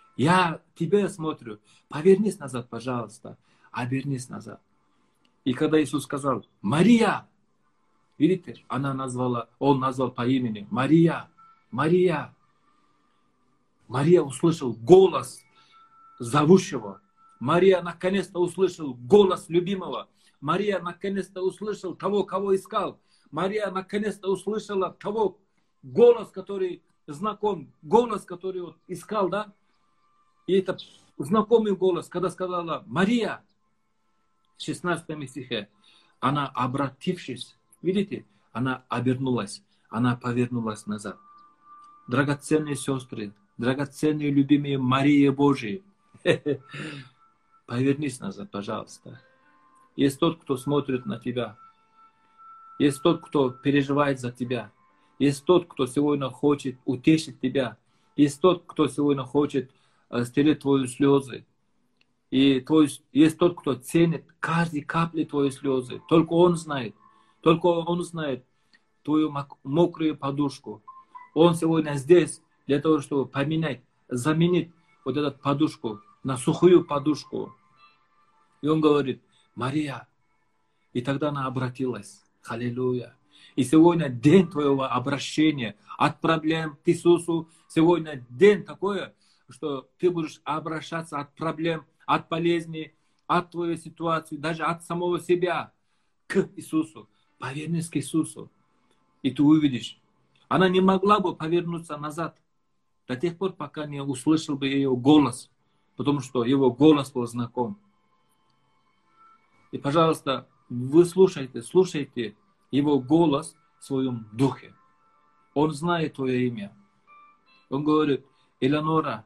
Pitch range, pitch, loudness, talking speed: 135-175 Hz, 150 Hz, -25 LUFS, 110 wpm